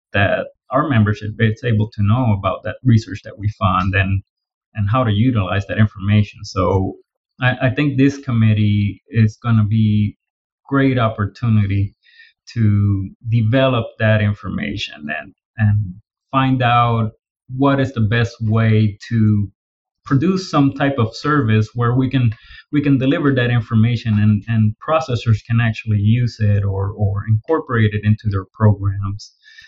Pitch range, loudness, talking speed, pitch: 105-125 Hz, -17 LUFS, 145 wpm, 110 Hz